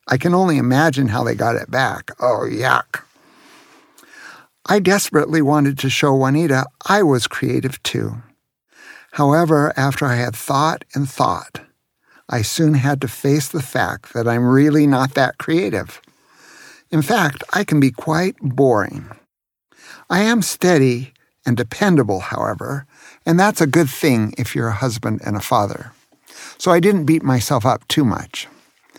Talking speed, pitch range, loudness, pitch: 155 wpm, 130-160 Hz, -17 LUFS, 140 Hz